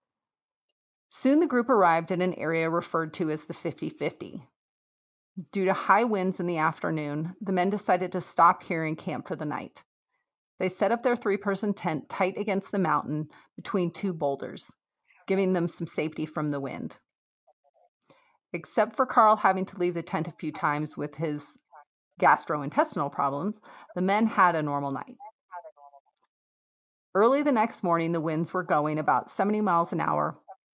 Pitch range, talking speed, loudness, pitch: 155-200 Hz, 170 wpm, -27 LUFS, 175 Hz